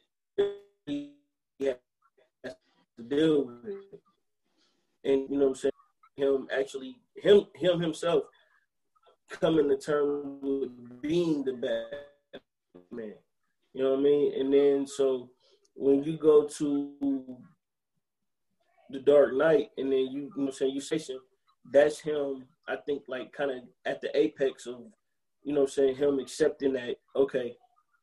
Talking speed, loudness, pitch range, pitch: 145 wpm, -28 LUFS, 135-160 Hz, 140 Hz